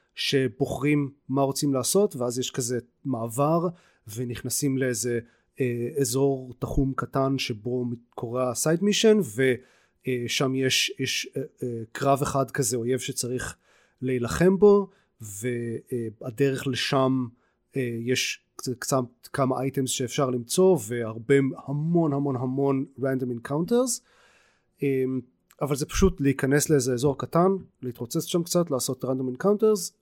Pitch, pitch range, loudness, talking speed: 135 Hz, 125-145 Hz, -26 LUFS, 120 wpm